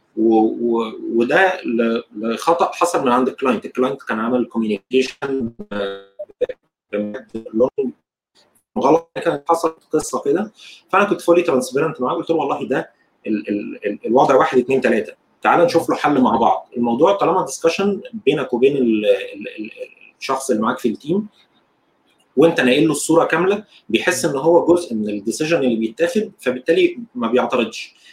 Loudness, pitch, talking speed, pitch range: -18 LUFS, 155 Hz, 145 wpm, 115-180 Hz